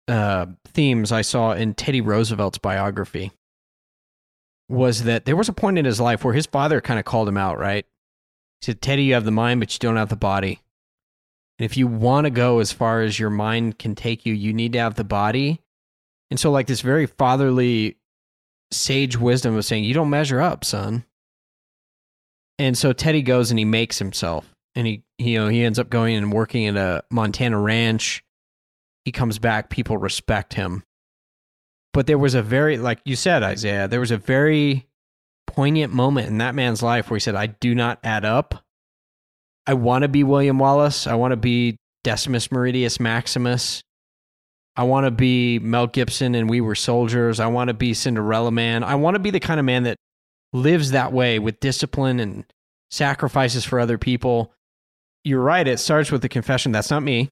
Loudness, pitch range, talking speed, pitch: -20 LUFS, 110-130 Hz, 195 wpm, 120 Hz